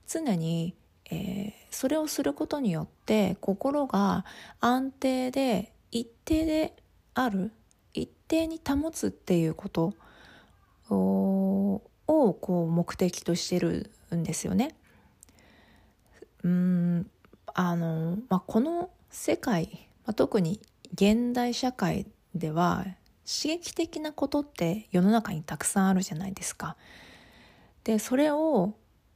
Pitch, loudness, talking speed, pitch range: 205 Hz, -29 LUFS, 210 characters per minute, 175-265 Hz